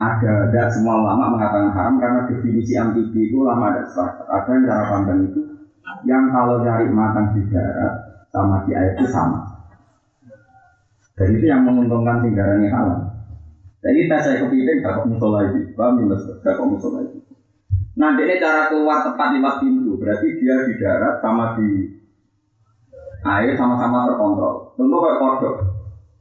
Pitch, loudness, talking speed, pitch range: 115 Hz, -18 LUFS, 160 wpm, 100-135 Hz